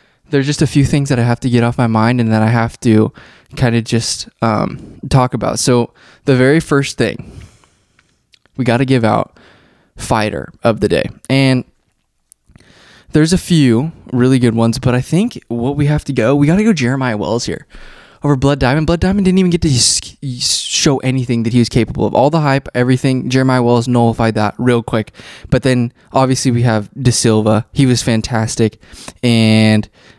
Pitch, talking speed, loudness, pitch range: 125 Hz, 195 wpm, -14 LUFS, 115-135 Hz